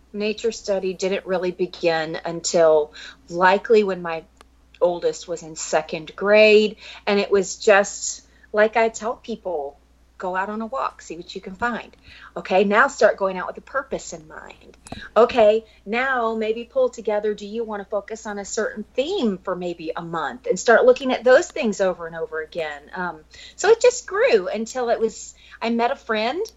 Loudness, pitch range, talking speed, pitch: -21 LUFS, 180-230 Hz, 185 wpm, 210 Hz